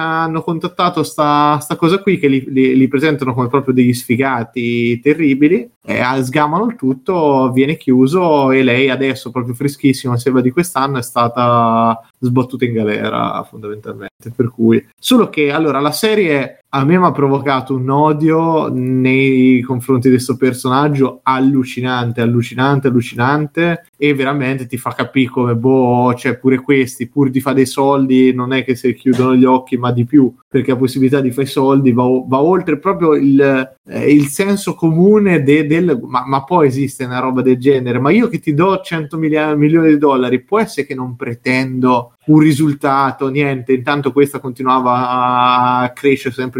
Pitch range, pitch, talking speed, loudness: 125-150 Hz, 135 Hz, 175 wpm, -14 LUFS